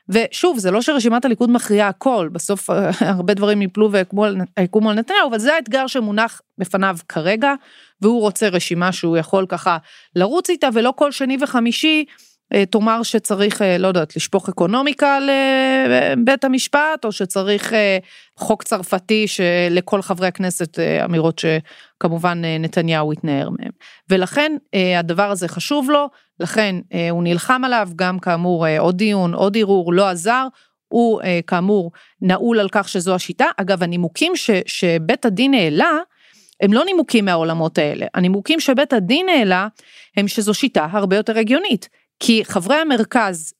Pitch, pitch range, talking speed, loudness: 205 Hz, 180-245 Hz, 140 wpm, -17 LUFS